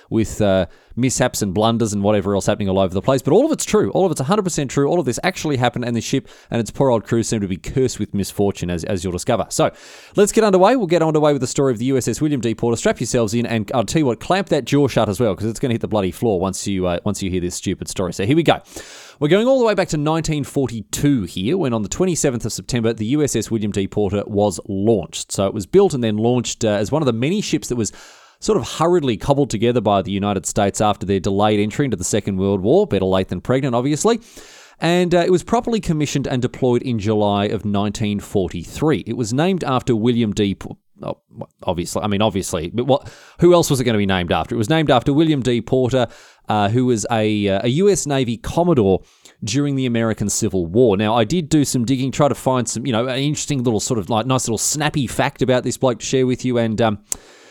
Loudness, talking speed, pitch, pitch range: -19 LUFS, 255 wpm, 120 Hz, 105-145 Hz